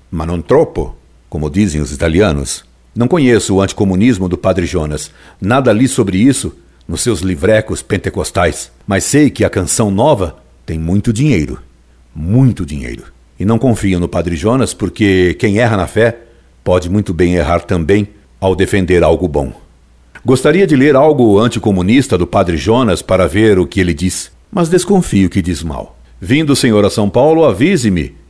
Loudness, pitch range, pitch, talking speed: -12 LUFS, 85-110 Hz, 95 Hz, 165 wpm